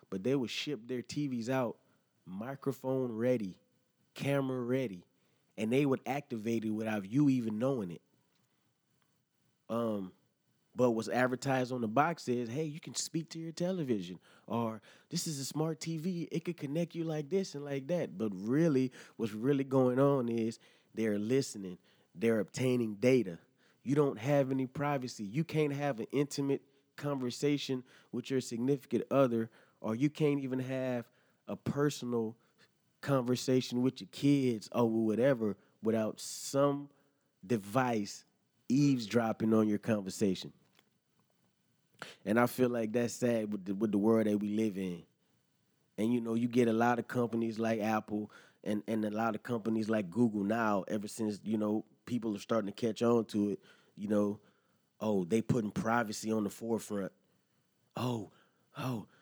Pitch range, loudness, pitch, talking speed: 110-140 Hz, -34 LUFS, 120 Hz, 160 wpm